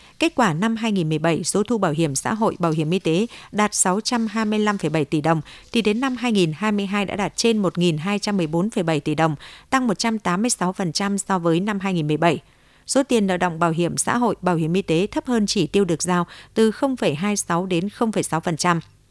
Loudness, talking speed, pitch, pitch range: -21 LUFS, 175 wpm, 190 Hz, 170-215 Hz